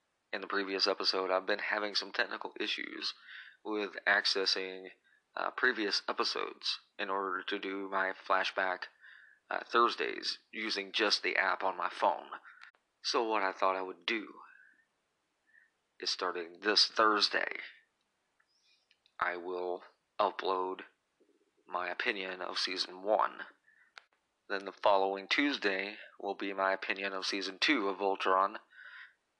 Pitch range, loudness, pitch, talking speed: 95-100 Hz, -33 LUFS, 95 Hz, 125 wpm